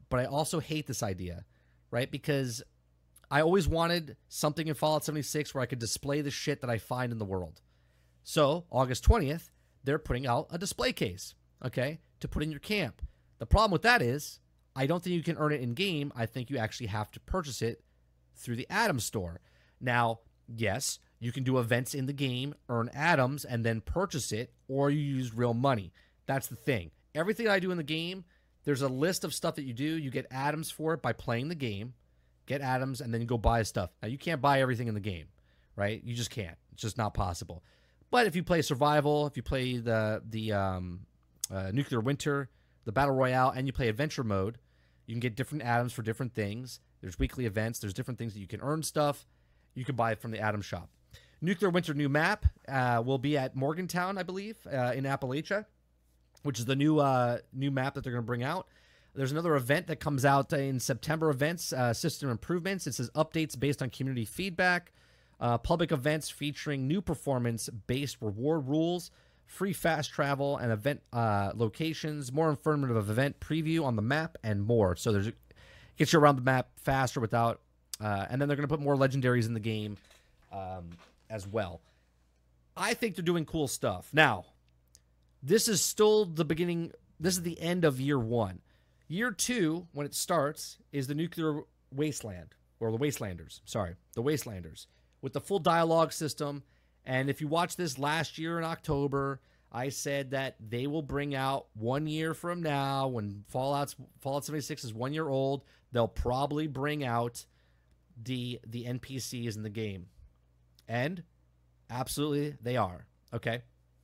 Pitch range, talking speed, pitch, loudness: 110-150 Hz, 190 wpm, 130 Hz, -32 LUFS